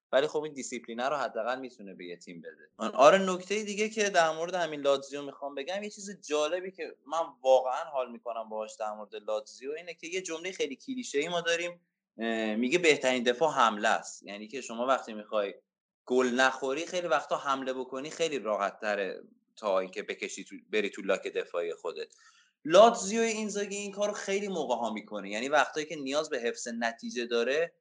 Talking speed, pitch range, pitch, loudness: 180 wpm, 125-205 Hz, 160 Hz, -30 LUFS